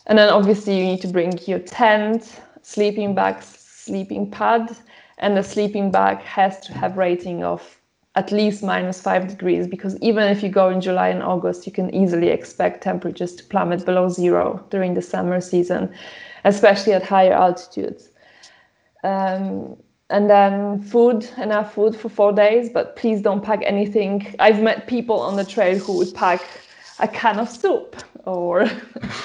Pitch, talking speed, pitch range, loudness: 195 Hz, 165 wpm, 180-210 Hz, -19 LUFS